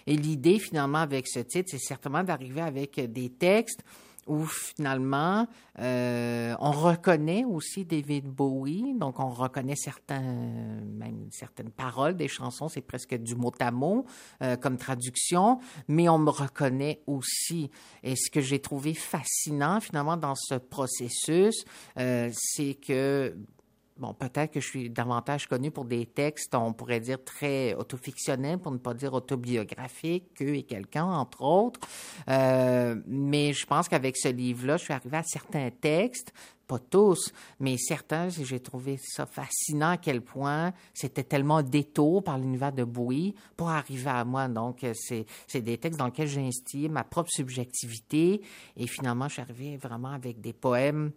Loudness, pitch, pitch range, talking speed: -29 LUFS, 140 Hz, 125-155 Hz, 160 wpm